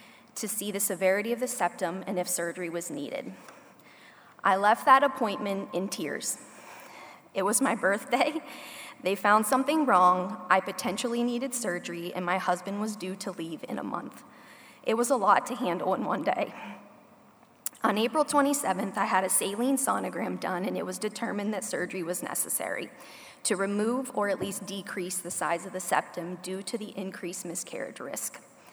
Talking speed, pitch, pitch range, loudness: 175 wpm, 200 Hz, 185-230 Hz, -29 LUFS